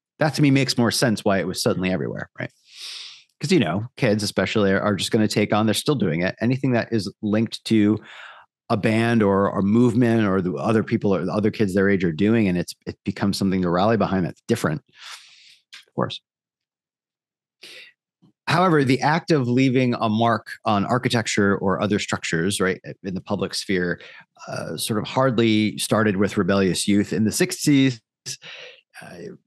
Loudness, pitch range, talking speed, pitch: -21 LUFS, 100-120 Hz, 185 wpm, 110 Hz